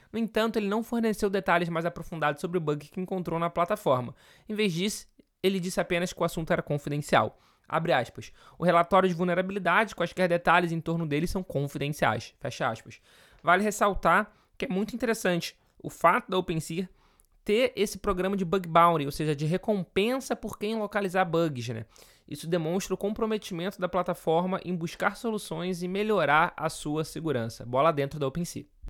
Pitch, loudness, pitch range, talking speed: 180 Hz, -28 LUFS, 165-200 Hz, 175 wpm